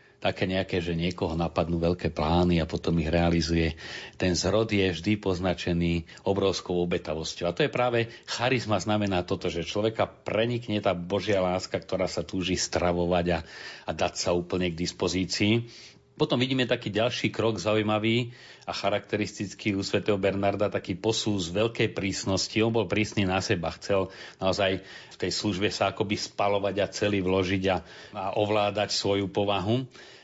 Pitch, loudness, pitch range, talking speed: 95 Hz, -27 LUFS, 90-105 Hz, 155 wpm